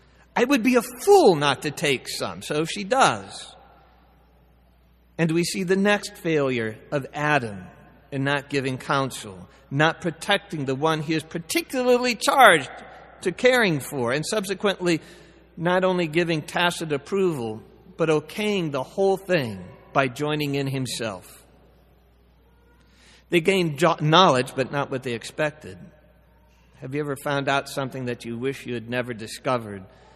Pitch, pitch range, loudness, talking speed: 150 Hz, 130-180 Hz, -23 LUFS, 145 wpm